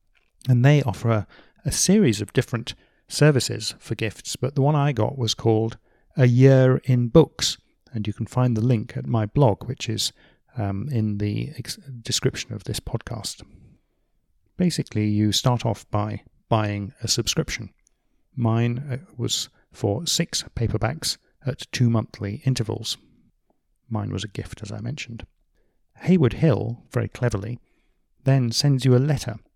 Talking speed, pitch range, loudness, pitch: 150 wpm, 110-130 Hz, -23 LUFS, 120 Hz